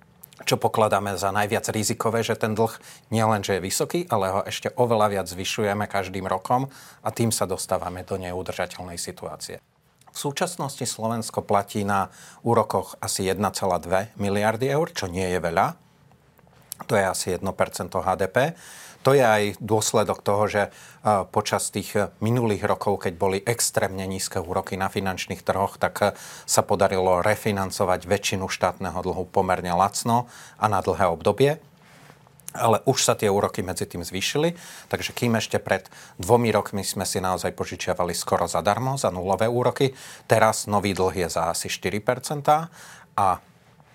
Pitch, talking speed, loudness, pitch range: 105 Hz, 145 wpm, -24 LUFS, 95-120 Hz